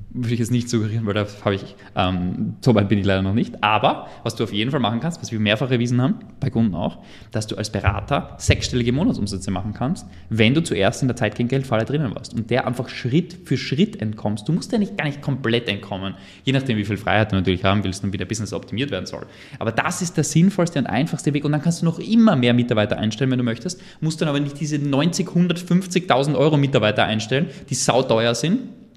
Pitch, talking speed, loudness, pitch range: 120 Hz, 235 wpm, -21 LUFS, 105-150 Hz